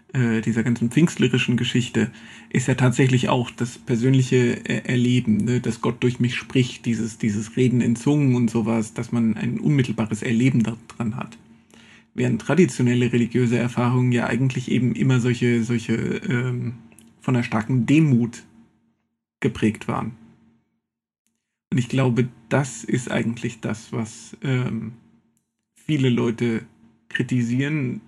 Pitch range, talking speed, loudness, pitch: 115-125 Hz, 130 wpm, -22 LUFS, 120 Hz